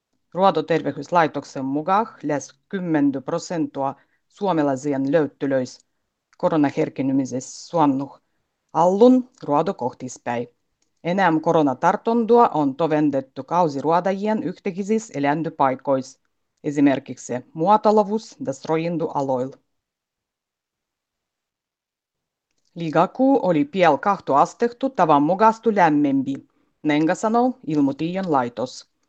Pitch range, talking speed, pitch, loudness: 140-200 Hz, 75 wpm, 160 Hz, -21 LUFS